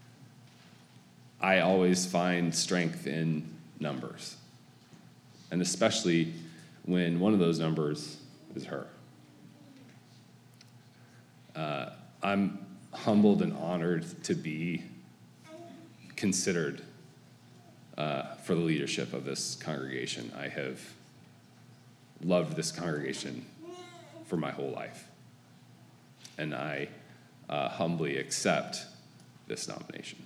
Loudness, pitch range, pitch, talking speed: -32 LUFS, 75-95 Hz, 85 Hz, 90 wpm